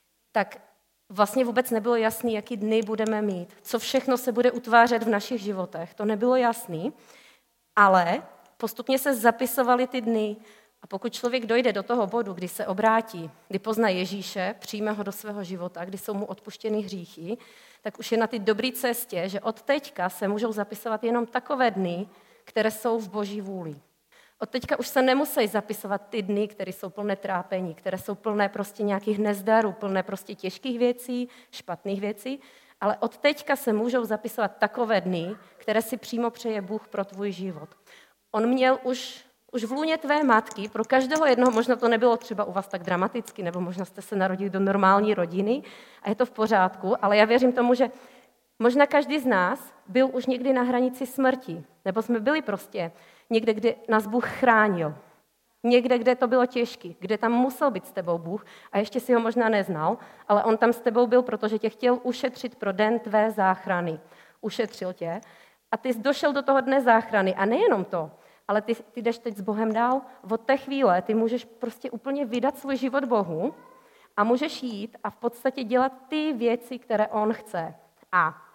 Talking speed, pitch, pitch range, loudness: 185 wpm, 225 Hz, 200-250 Hz, -25 LUFS